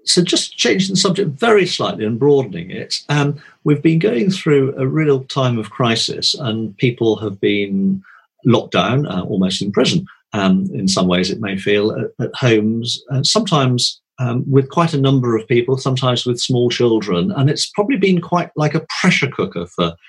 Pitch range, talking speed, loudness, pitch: 110-150 Hz, 190 wpm, -16 LUFS, 130 Hz